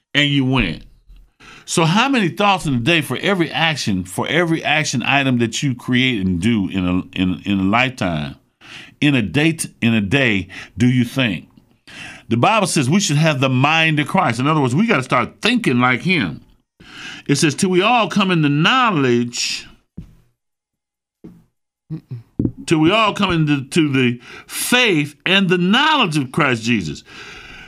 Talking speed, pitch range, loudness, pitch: 170 wpm, 120-170 Hz, -16 LUFS, 145 Hz